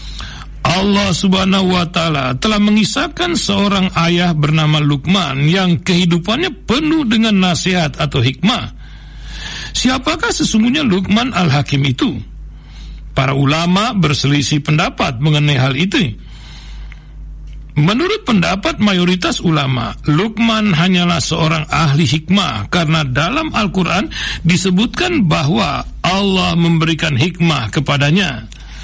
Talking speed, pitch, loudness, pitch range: 100 wpm, 175 Hz, -14 LUFS, 150-200 Hz